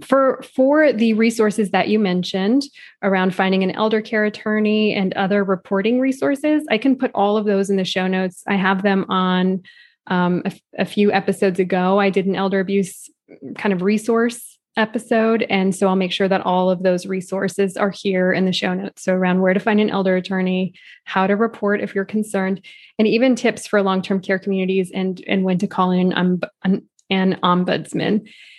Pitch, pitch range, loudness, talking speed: 195 Hz, 185-215 Hz, -19 LUFS, 200 wpm